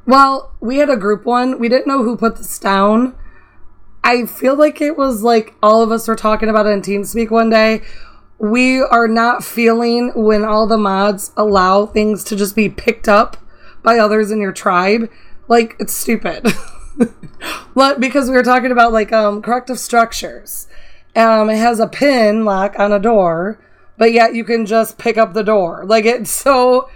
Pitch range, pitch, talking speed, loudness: 215-240 Hz, 225 Hz, 185 wpm, -13 LUFS